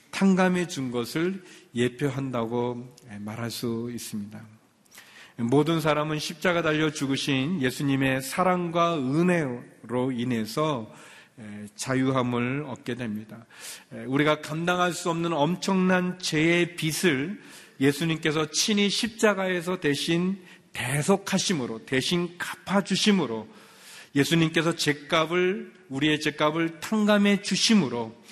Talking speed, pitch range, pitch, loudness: 250 characters per minute, 125-180 Hz, 155 Hz, -25 LUFS